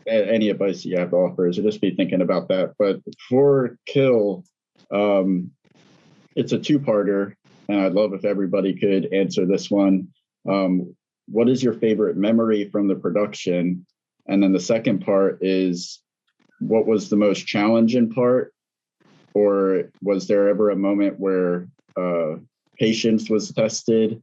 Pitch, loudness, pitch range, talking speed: 100 Hz, -21 LUFS, 95-110 Hz, 155 wpm